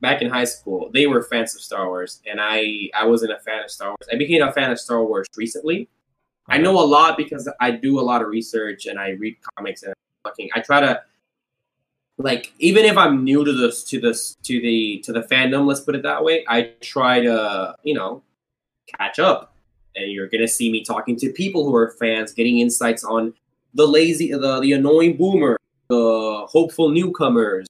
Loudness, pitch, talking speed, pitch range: -19 LUFS, 120 Hz, 210 wpm, 115-145 Hz